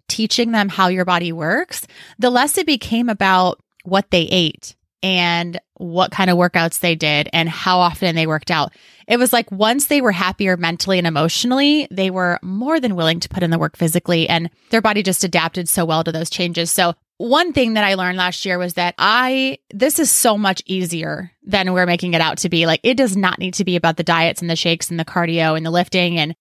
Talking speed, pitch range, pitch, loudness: 230 wpm, 170-205 Hz, 180 Hz, -17 LUFS